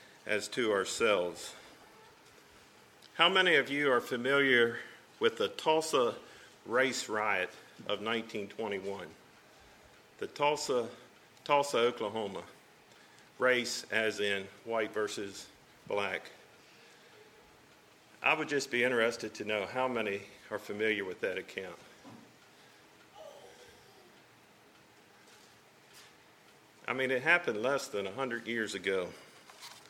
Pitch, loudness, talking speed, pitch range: 120 Hz, -32 LUFS, 100 wpm, 105-140 Hz